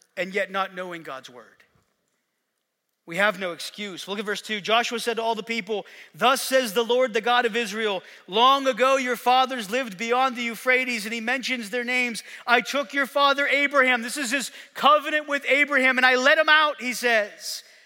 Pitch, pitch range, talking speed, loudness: 245 Hz, 220-265 Hz, 200 wpm, -22 LUFS